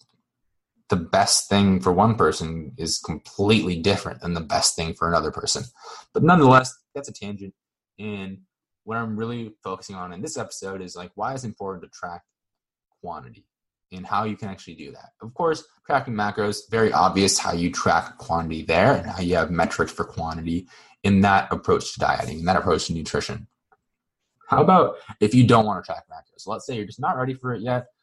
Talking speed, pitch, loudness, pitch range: 195 wpm, 100 Hz, -22 LUFS, 90-115 Hz